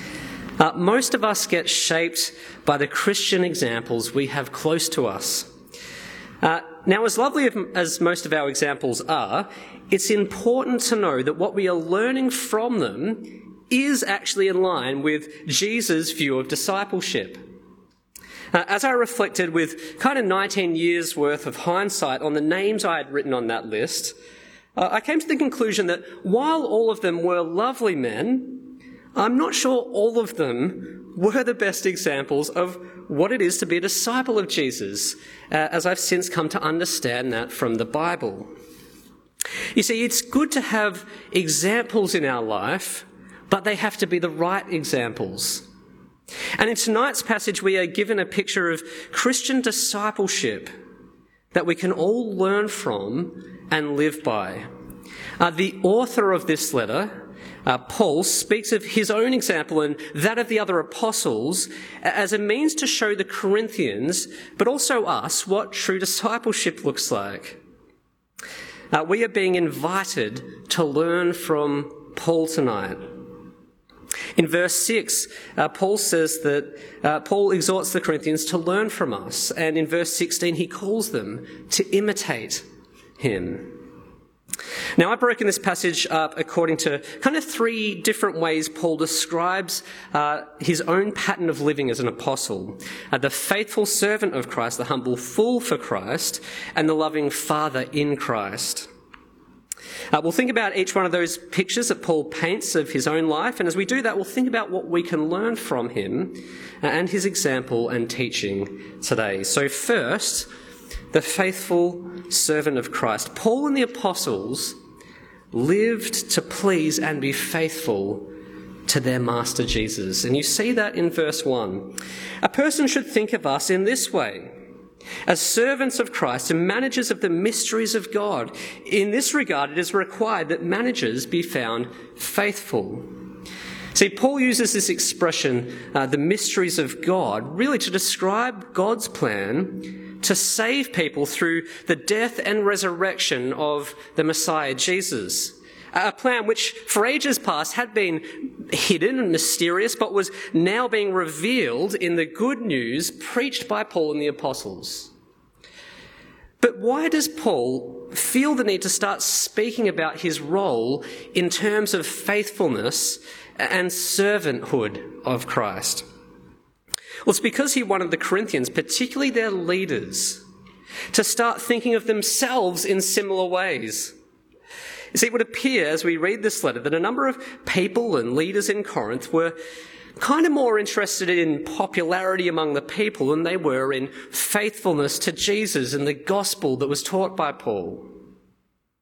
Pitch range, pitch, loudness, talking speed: 155-220 Hz, 185 Hz, -22 LUFS, 155 wpm